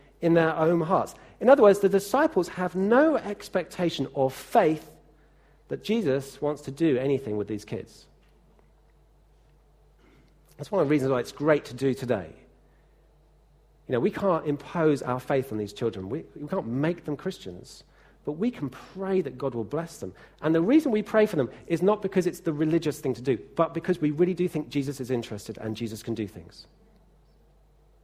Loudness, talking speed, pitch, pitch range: -26 LUFS, 190 wpm, 150 Hz, 130-180 Hz